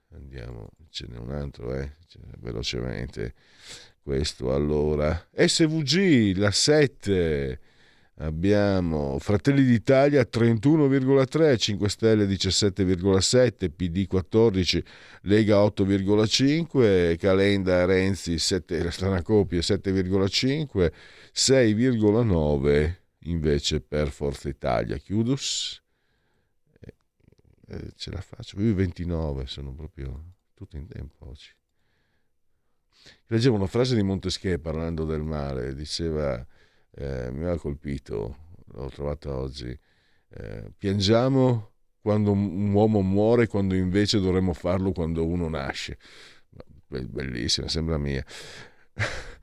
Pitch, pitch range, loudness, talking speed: 95 Hz, 75-105 Hz, -24 LUFS, 95 wpm